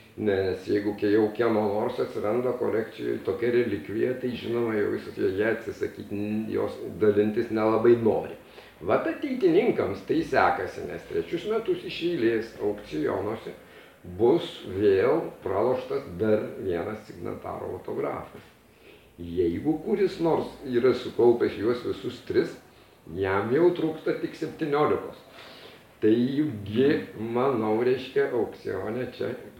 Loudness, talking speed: -27 LUFS, 115 wpm